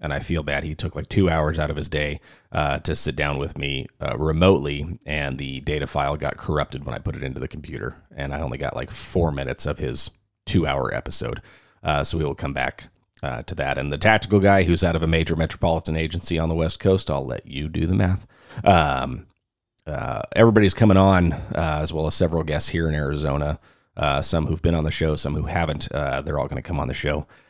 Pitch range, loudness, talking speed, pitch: 70-85 Hz, -22 LUFS, 240 wpm, 80 Hz